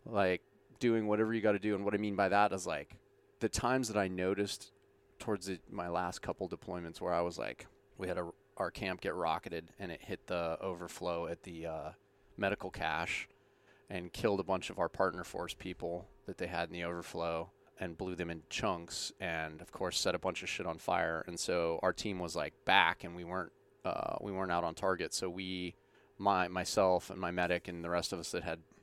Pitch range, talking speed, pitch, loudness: 85-100 Hz, 225 wpm, 90 Hz, -36 LUFS